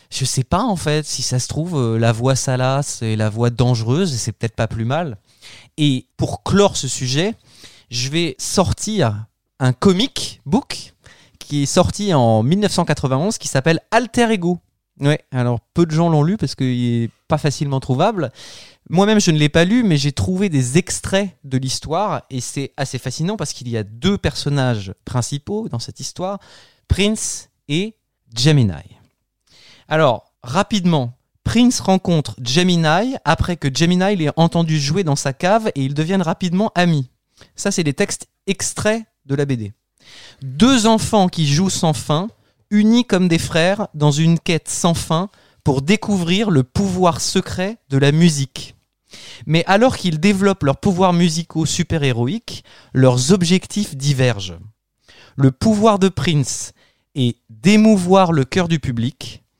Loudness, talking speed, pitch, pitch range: -18 LUFS, 155 wpm, 150 Hz, 125-185 Hz